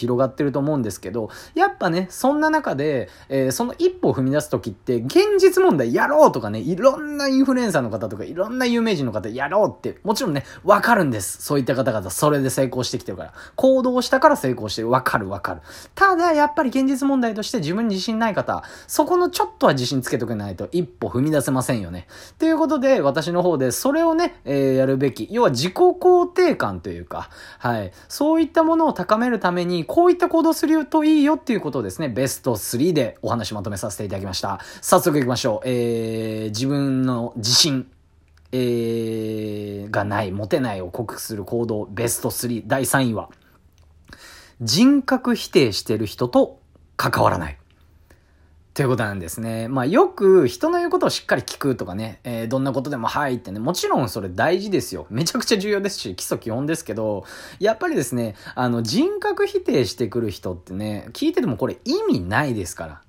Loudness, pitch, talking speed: -21 LUFS, 135 Hz, 400 characters per minute